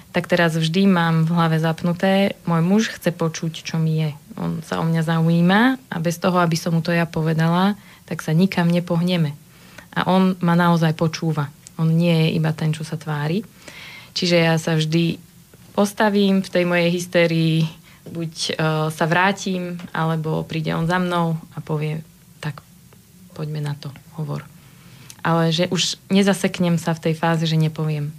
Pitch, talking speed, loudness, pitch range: 165 Hz, 170 wpm, -20 LUFS, 160-175 Hz